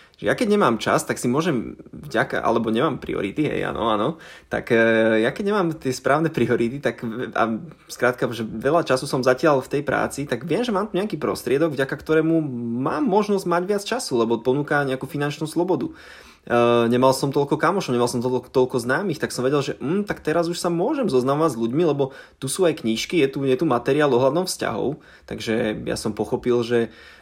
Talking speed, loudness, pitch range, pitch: 205 wpm, -22 LUFS, 120-165 Hz, 135 Hz